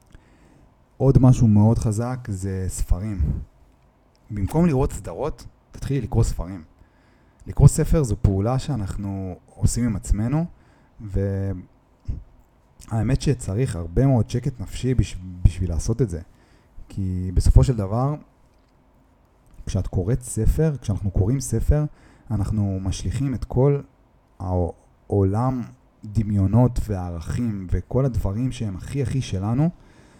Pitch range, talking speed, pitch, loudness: 95-125 Hz, 105 wpm, 105 Hz, -23 LUFS